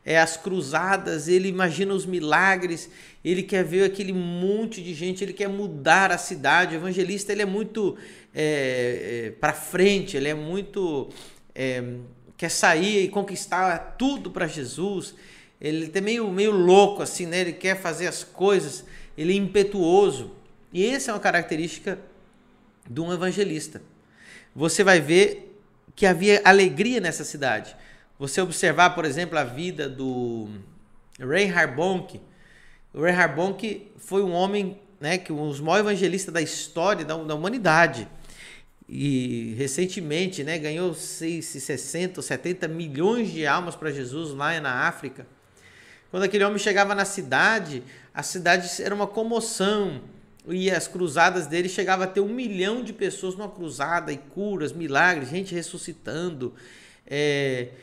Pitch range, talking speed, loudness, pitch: 155-195 Hz, 150 wpm, -24 LUFS, 180 Hz